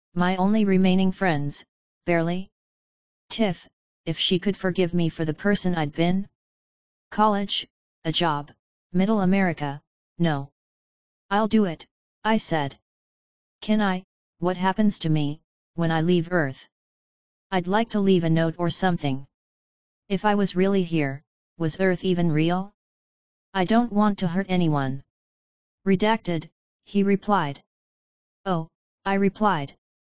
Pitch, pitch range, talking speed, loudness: 180 Hz, 160-195 Hz, 130 wpm, -24 LUFS